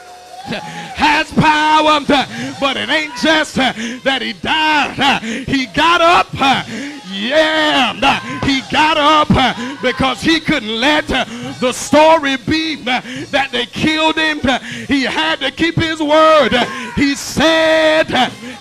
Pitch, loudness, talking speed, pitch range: 285 Hz, -13 LUFS, 115 wpm, 255-310 Hz